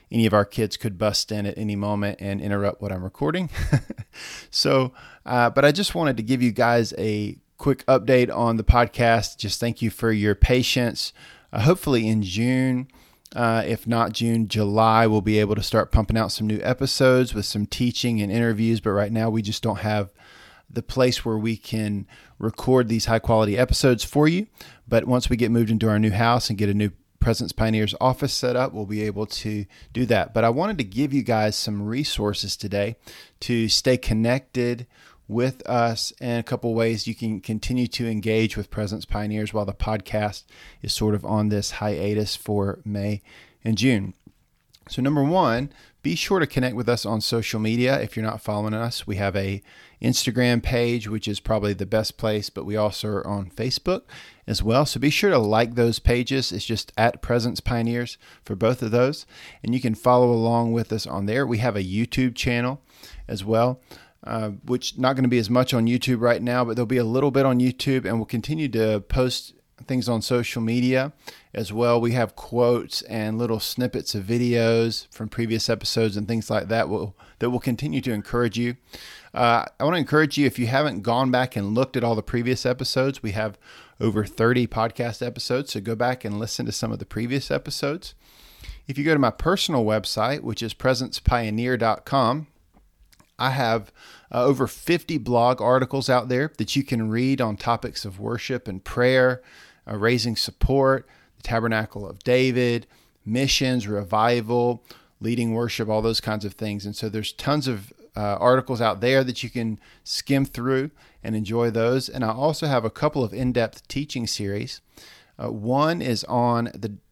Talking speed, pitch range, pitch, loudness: 195 wpm, 110-125 Hz, 115 Hz, -23 LUFS